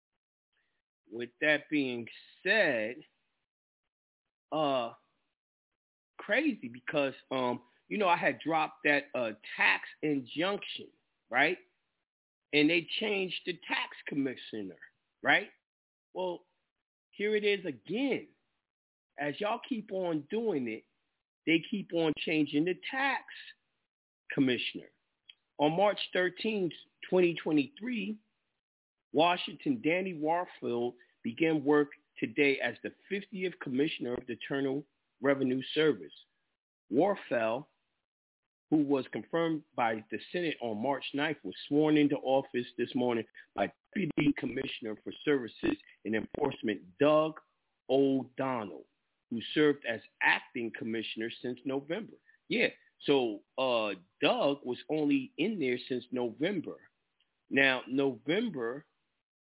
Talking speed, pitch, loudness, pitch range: 105 wpm, 150 Hz, -32 LUFS, 130-190 Hz